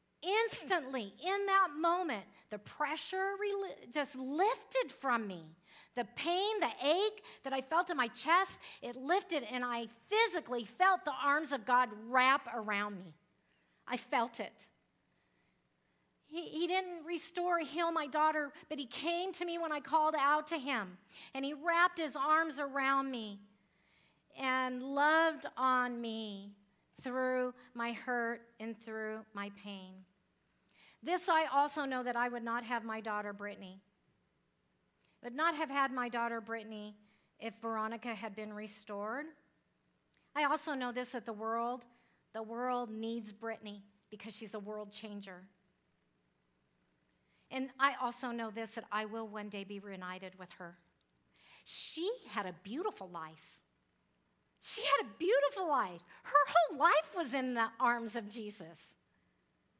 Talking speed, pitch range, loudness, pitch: 145 wpm, 210-305 Hz, -36 LUFS, 245 Hz